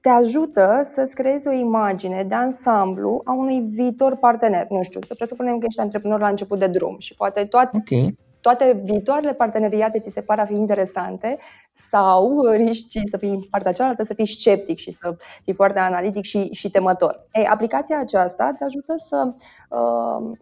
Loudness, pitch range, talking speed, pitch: -20 LUFS, 195-250 Hz, 175 wpm, 215 Hz